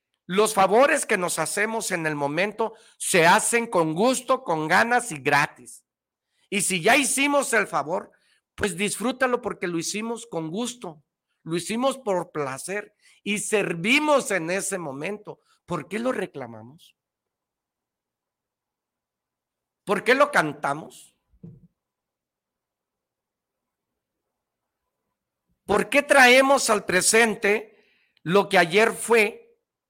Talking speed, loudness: 110 wpm, -22 LUFS